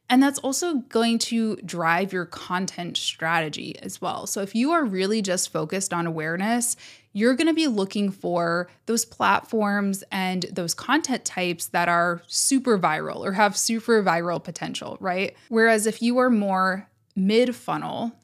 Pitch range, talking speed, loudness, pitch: 180-230 Hz, 160 wpm, -24 LUFS, 205 Hz